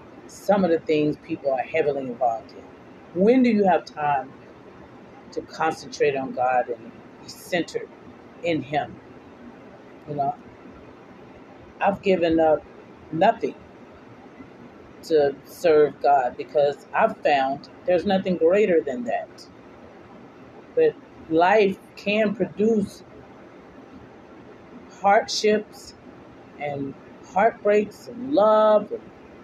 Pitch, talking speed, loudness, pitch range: 195 Hz, 100 wpm, -22 LUFS, 155-215 Hz